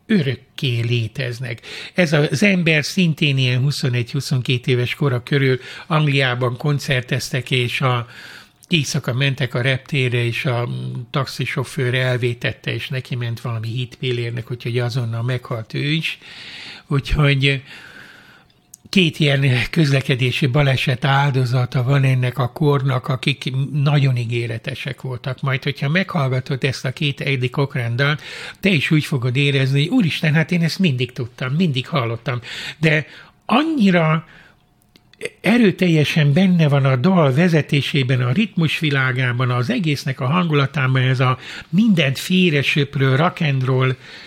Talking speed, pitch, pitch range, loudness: 120 wpm, 140 Hz, 125-155 Hz, -18 LUFS